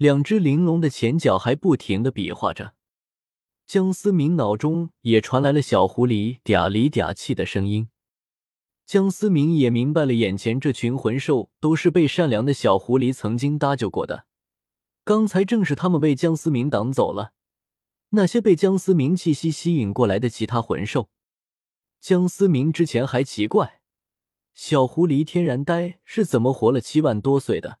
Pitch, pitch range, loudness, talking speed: 140 Hz, 115-170 Hz, -21 LUFS, 250 characters per minute